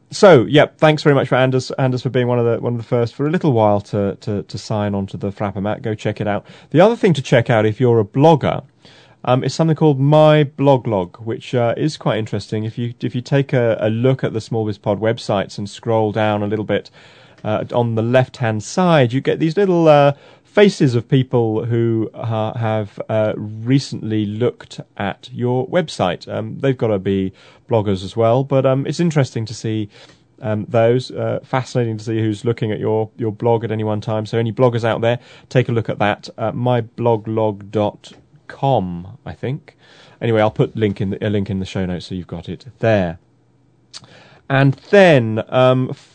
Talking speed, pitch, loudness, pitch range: 210 wpm, 115 Hz, -17 LUFS, 110-135 Hz